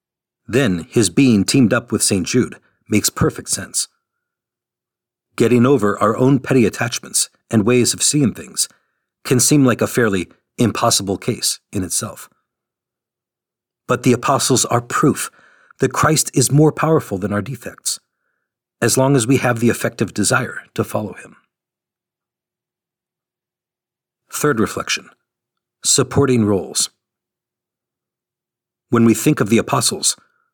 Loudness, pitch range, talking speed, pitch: -17 LUFS, 115-140 Hz, 130 wpm, 125 Hz